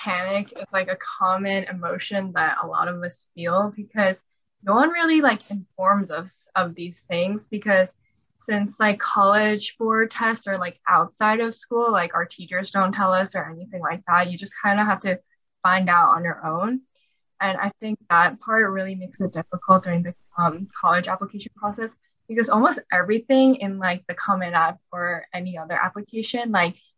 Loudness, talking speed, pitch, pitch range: -22 LUFS, 180 wpm, 195 Hz, 180-215 Hz